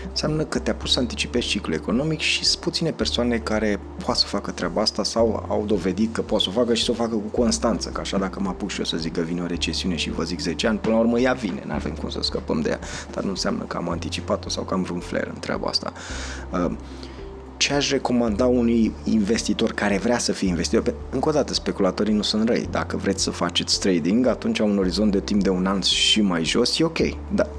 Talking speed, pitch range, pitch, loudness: 245 wpm, 85-115 Hz, 105 Hz, -23 LUFS